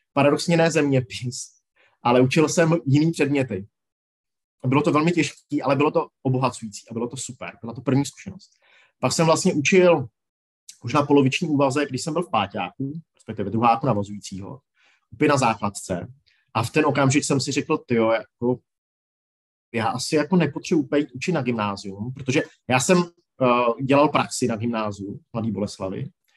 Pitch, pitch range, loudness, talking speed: 135 Hz, 115-150 Hz, -22 LUFS, 160 wpm